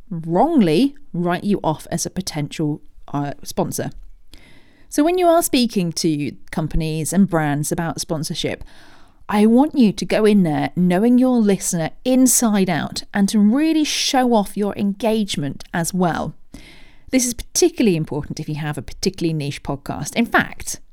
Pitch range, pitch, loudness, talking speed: 160-230 Hz, 185 Hz, -19 LUFS, 155 wpm